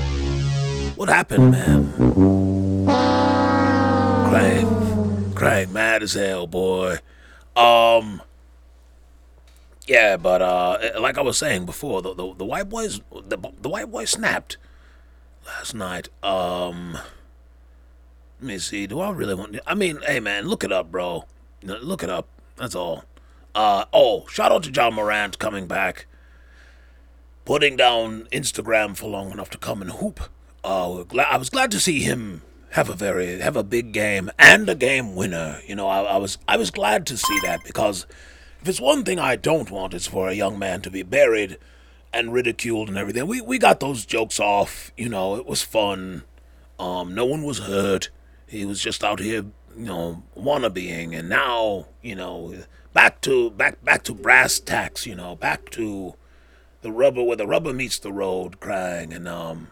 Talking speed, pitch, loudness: 170 wpm, 90 Hz, -20 LUFS